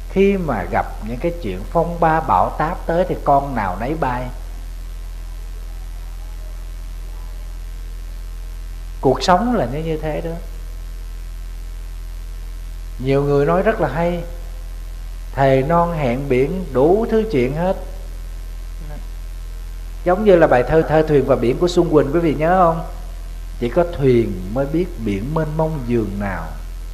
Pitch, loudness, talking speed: 110 Hz, -18 LUFS, 140 wpm